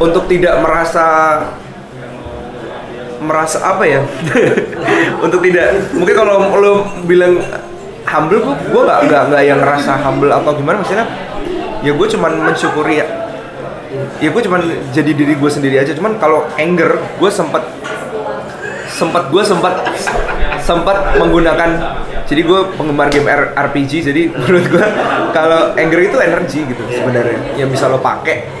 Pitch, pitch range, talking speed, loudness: 155 Hz, 140-175 Hz, 135 wpm, -12 LUFS